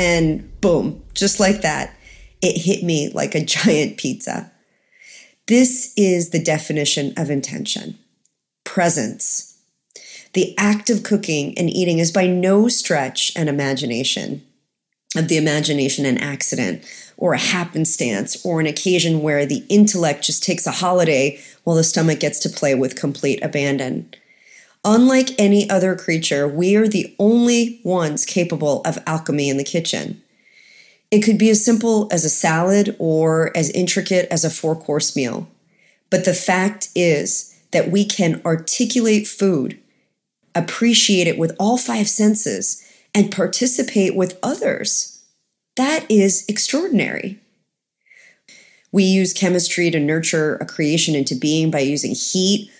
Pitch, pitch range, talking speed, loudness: 180 Hz, 155-205 Hz, 140 wpm, -17 LUFS